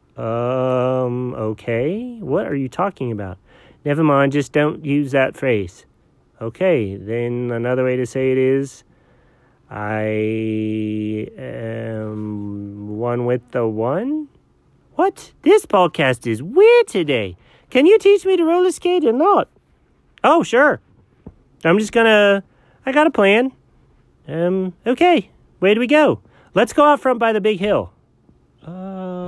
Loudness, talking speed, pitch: -18 LUFS, 135 wpm, 140 Hz